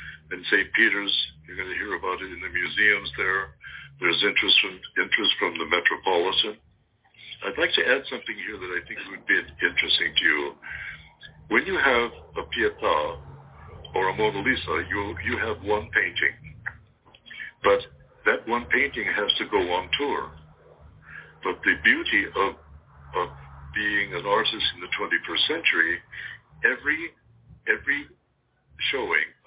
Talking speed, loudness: 145 wpm, -23 LUFS